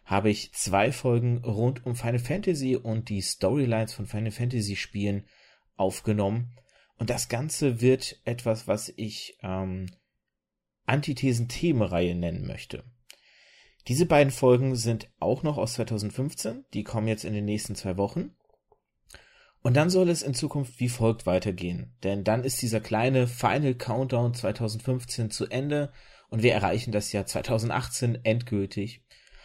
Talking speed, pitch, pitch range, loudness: 140 wpm, 115 Hz, 105-130 Hz, -28 LUFS